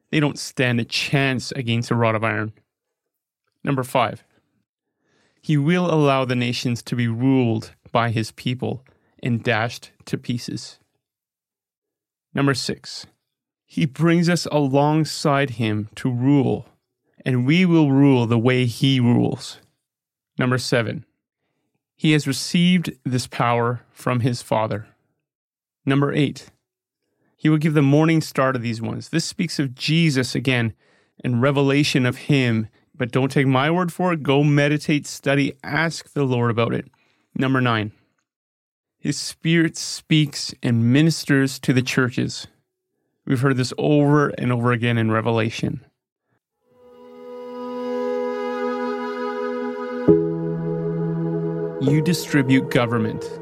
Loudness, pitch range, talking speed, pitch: -21 LUFS, 115-145 Hz, 125 wpm, 130 Hz